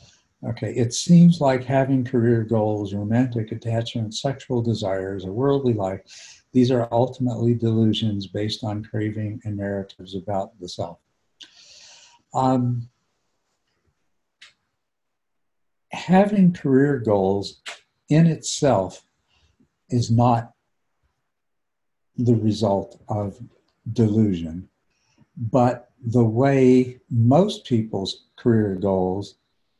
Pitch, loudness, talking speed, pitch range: 115 Hz, -21 LUFS, 90 wpm, 105-125 Hz